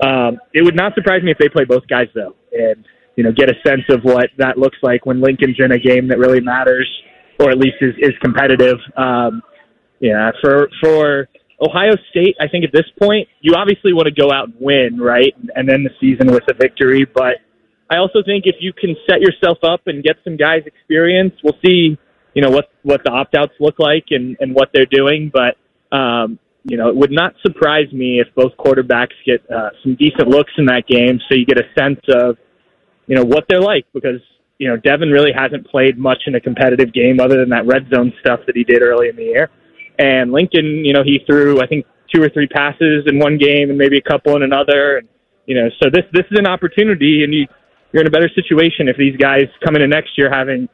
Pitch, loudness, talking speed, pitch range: 140 Hz, -13 LUFS, 230 wpm, 130-160 Hz